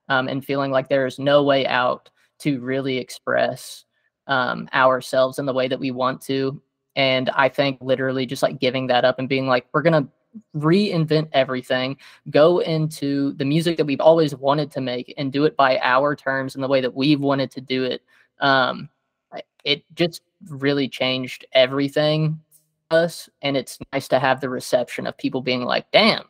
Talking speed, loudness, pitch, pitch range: 190 wpm, -21 LUFS, 135 Hz, 130-150 Hz